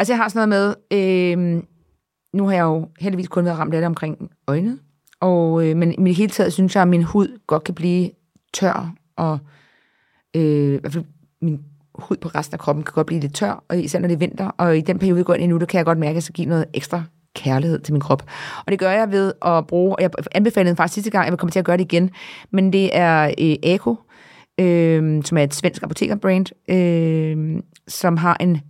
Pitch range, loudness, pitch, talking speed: 160-185 Hz, -19 LUFS, 175 Hz, 240 wpm